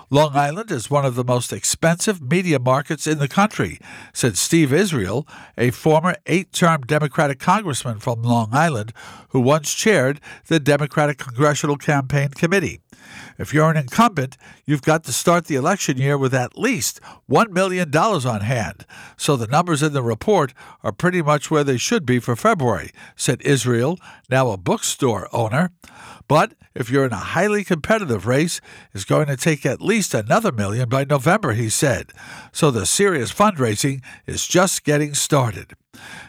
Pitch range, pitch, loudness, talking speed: 130-165 Hz, 145 Hz, -19 LUFS, 165 wpm